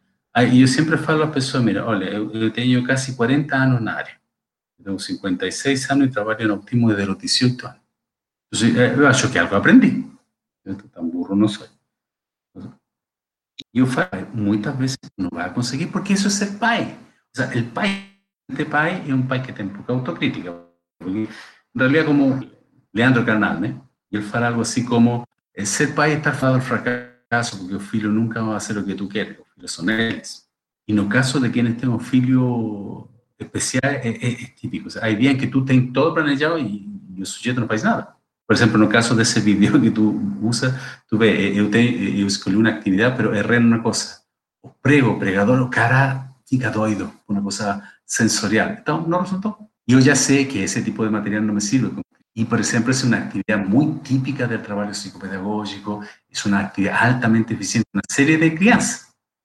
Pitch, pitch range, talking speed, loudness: 120 Hz, 105-135 Hz, 195 wpm, -19 LUFS